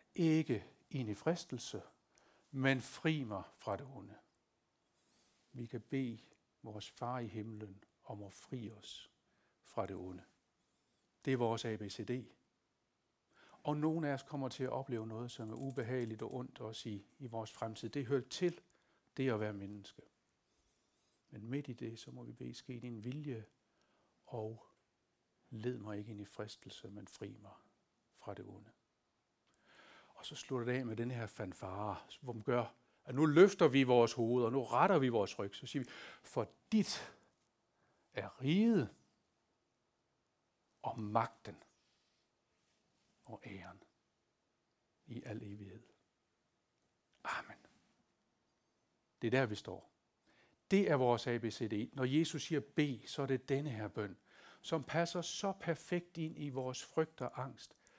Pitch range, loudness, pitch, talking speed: 110-140 Hz, -39 LUFS, 125 Hz, 150 wpm